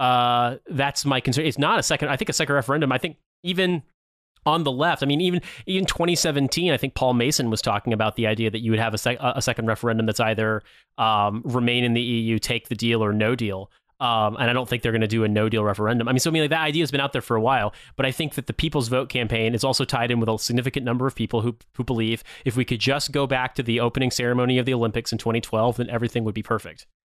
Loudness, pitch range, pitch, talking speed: -23 LUFS, 115-140 Hz, 125 Hz, 275 wpm